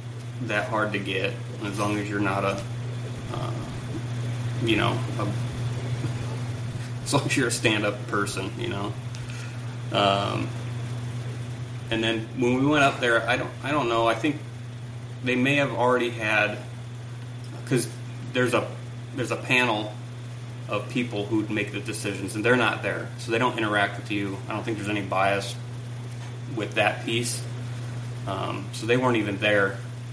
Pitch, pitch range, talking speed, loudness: 120 Hz, 115-120 Hz, 160 wpm, -26 LUFS